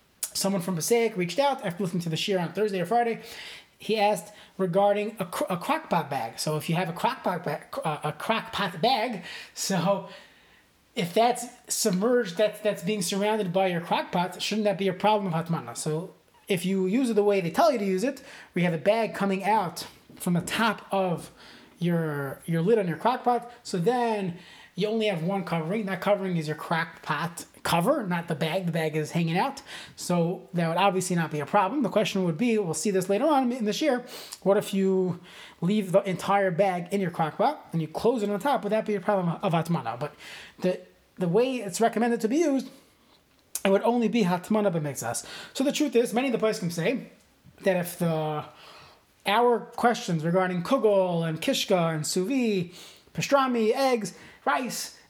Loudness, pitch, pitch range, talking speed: -27 LUFS, 195 Hz, 175-220 Hz, 200 wpm